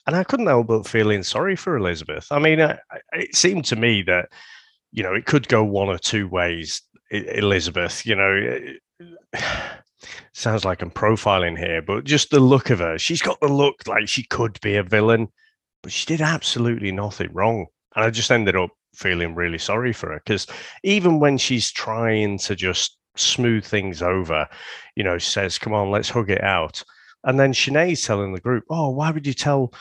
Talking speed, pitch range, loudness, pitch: 200 wpm, 100-140 Hz, -20 LUFS, 110 Hz